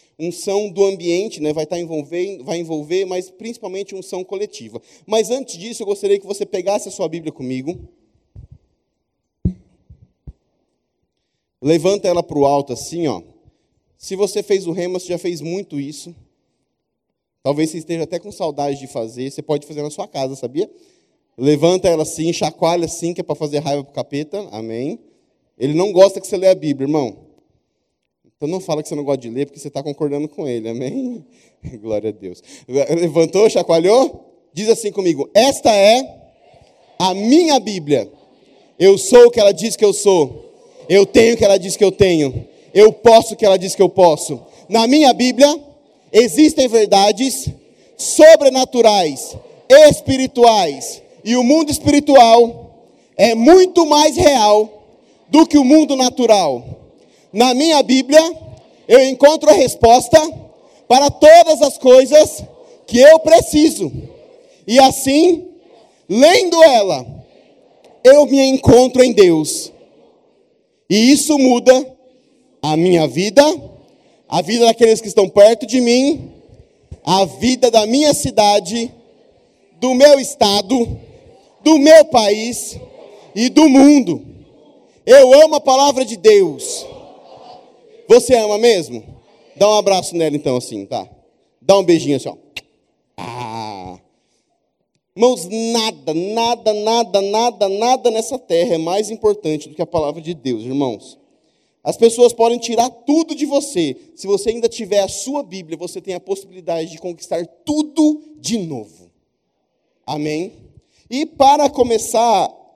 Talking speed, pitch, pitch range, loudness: 145 wpm, 210 Hz, 165-270 Hz, -13 LUFS